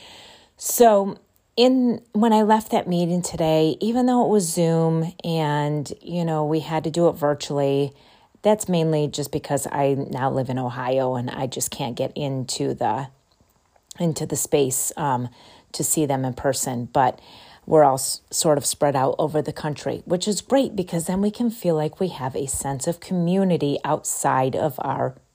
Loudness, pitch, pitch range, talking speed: -22 LUFS, 155 Hz, 140-180 Hz, 180 wpm